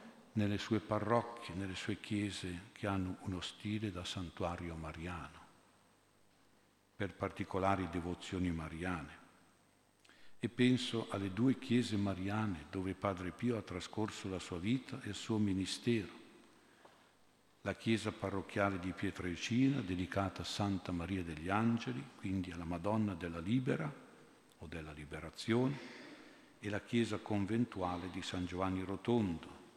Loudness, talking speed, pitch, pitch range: -39 LUFS, 125 wpm, 100 Hz, 90-110 Hz